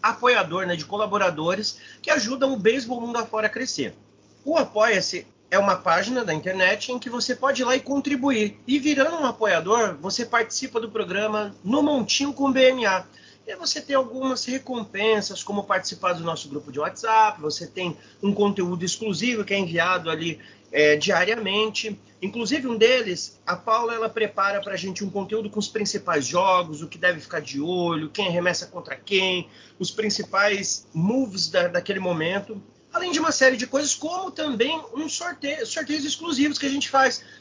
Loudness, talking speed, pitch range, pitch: -23 LUFS, 175 wpm, 185-260 Hz, 215 Hz